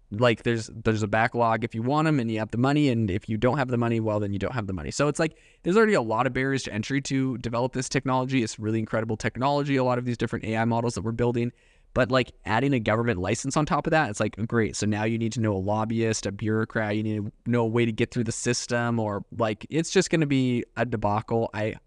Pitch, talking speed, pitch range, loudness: 115 Hz, 275 wpm, 110-130 Hz, -26 LUFS